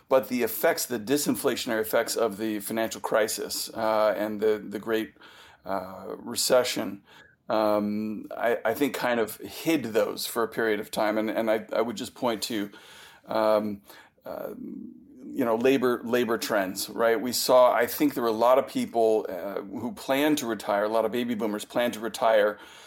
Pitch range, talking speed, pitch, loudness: 110-130 Hz, 180 wpm, 115 Hz, -26 LUFS